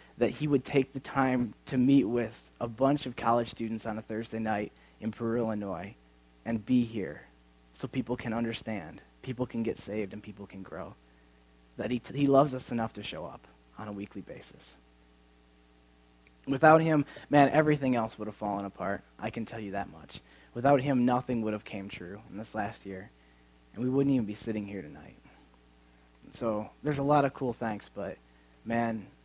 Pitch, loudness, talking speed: 110 Hz, -30 LUFS, 195 wpm